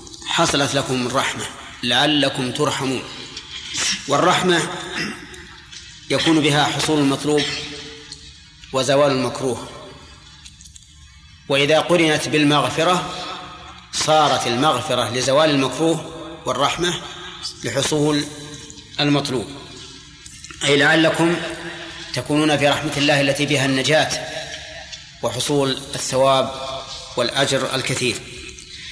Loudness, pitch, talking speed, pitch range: -19 LUFS, 145 Hz, 75 wpm, 130-155 Hz